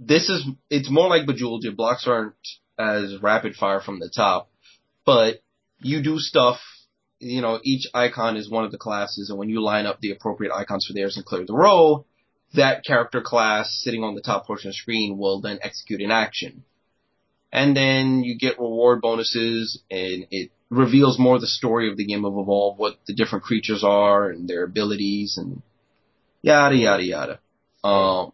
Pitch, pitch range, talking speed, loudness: 110 Hz, 100-125 Hz, 185 wpm, -21 LUFS